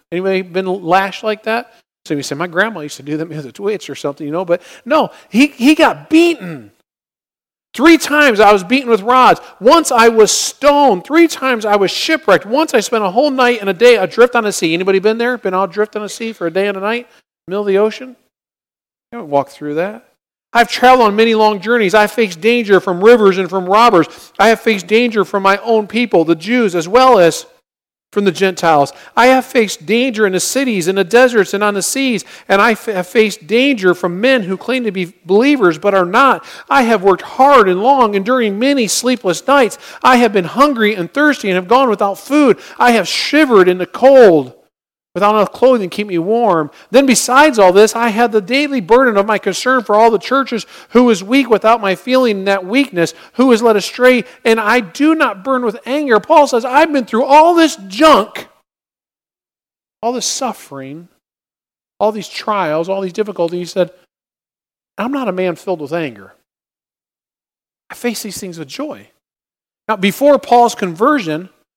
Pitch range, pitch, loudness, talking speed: 190-255 Hz, 220 Hz, -12 LUFS, 205 wpm